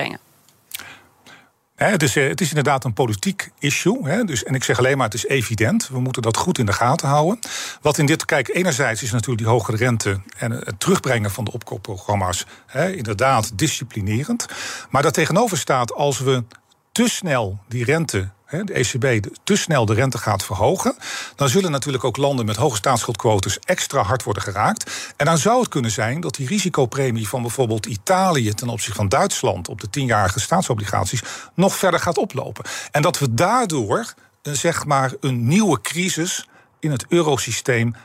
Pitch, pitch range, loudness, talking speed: 130 Hz, 115-155 Hz, -20 LUFS, 175 wpm